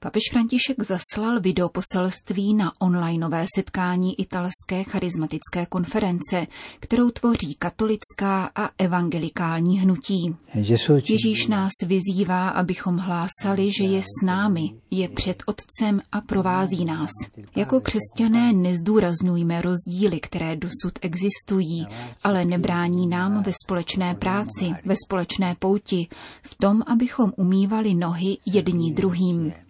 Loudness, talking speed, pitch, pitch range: -22 LUFS, 110 wpm, 185 Hz, 175-200 Hz